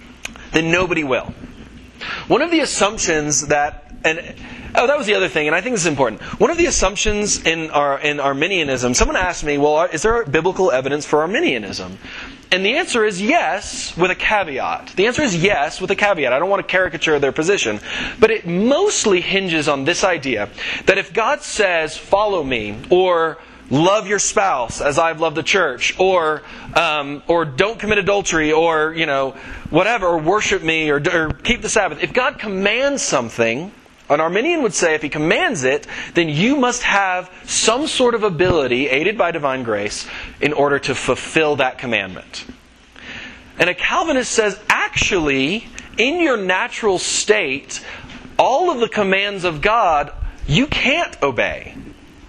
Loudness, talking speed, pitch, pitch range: -17 LUFS, 170 wpm, 180 Hz, 150-215 Hz